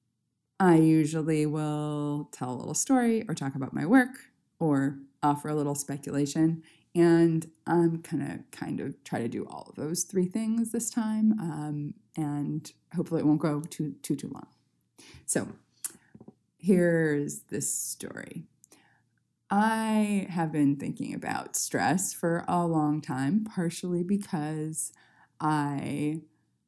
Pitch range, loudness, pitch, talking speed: 150-180 Hz, -29 LUFS, 160 Hz, 135 wpm